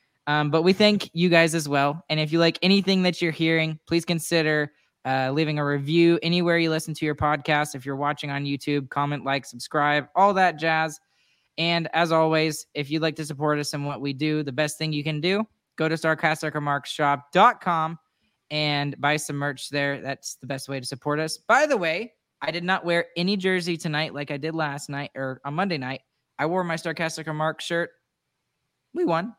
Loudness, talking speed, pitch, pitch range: -24 LUFS, 205 wpm, 155 Hz, 145-165 Hz